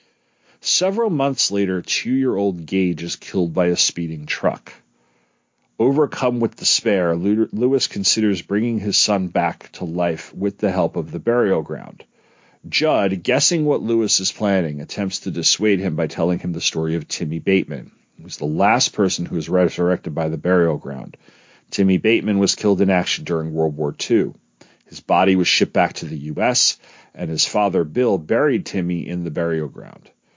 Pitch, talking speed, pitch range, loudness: 95 Hz, 175 wpm, 85-105 Hz, -19 LUFS